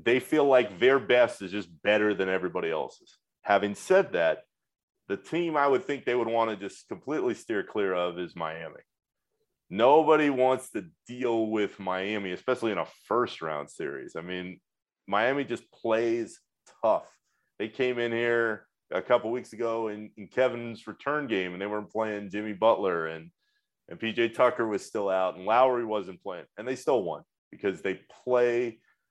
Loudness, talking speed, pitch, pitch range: -28 LUFS, 175 wpm, 115 Hz, 100-125 Hz